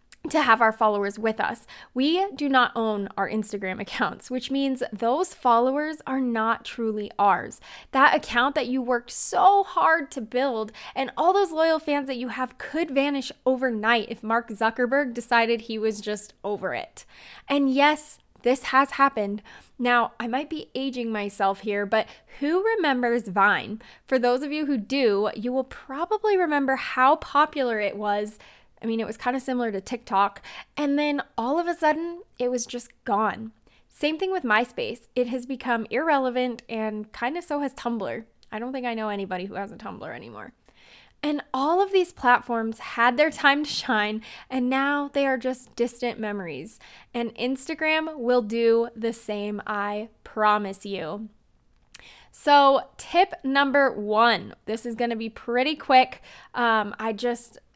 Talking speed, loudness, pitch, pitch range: 170 wpm, -24 LUFS, 245 Hz, 220-280 Hz